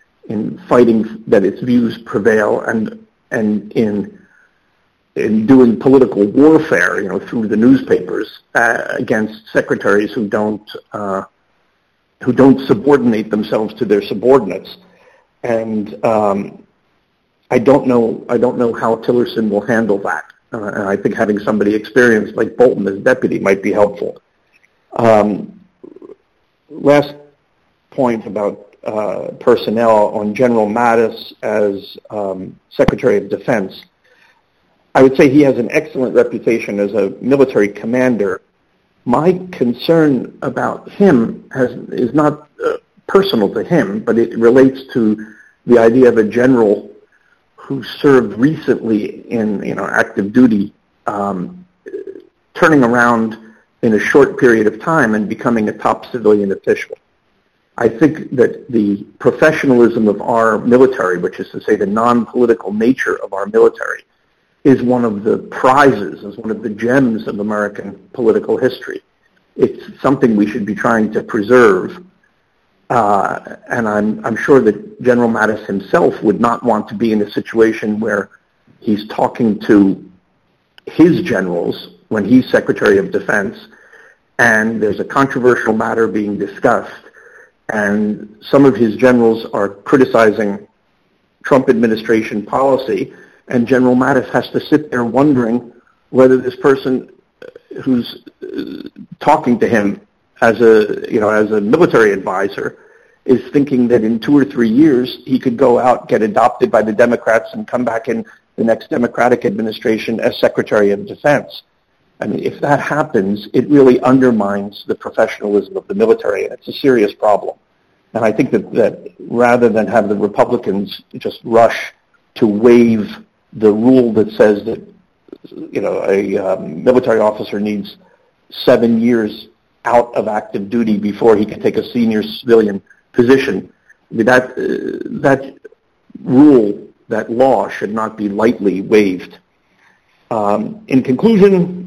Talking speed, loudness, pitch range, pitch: 140 wpm, -14 LUFS, 105-140 Hz, 120 Hz